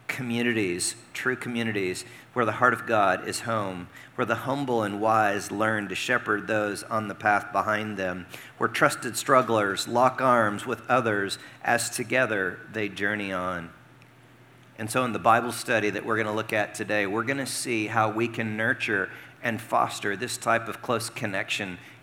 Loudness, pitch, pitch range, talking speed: -26 LUFS, 110 Hz, 105-120 Hz, 175 wpm